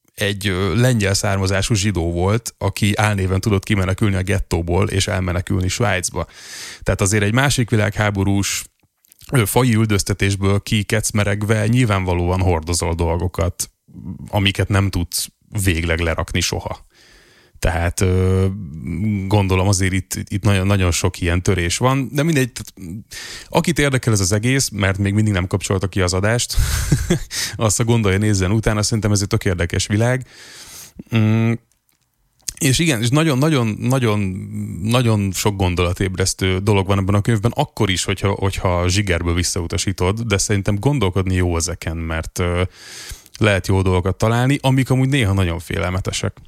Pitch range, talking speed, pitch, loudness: 95-110 Hz, 130 wpm, 100 Hz, -18 LUFS